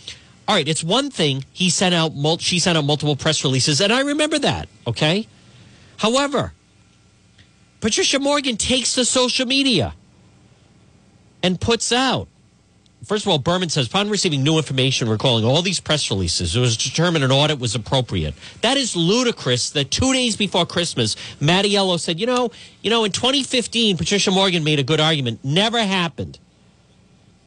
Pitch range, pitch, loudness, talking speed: 135-220 Hz, 175 Hz, -18 LUFS, 160 wpm